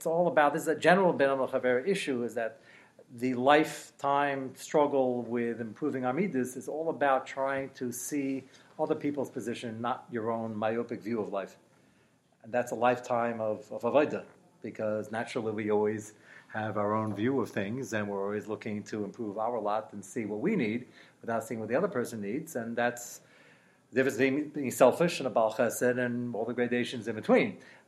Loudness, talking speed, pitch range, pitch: -31 LUFS, 185 wpm, 110-135 Hz, 125 Hz